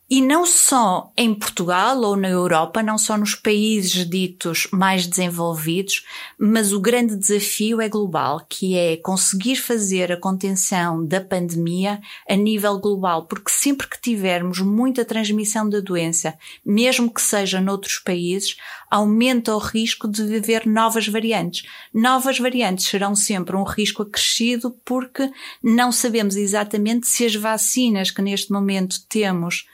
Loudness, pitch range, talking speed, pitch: -19 LUFS, 190-230 Hz, 140 wpm, 210 Hz